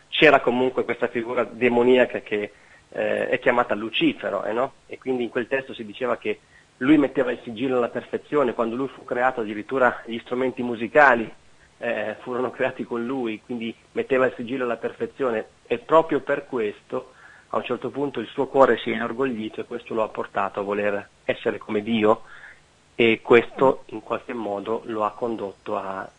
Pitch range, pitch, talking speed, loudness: 110-125 Hz, 120 Hz, 180 wpm, -23 LUFS